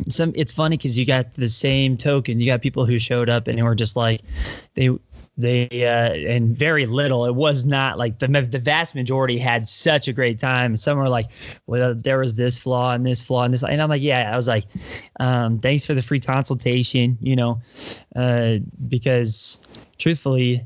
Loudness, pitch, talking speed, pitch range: -20 LUFS, 125 Hz, 205 wpm, 120-135 Hz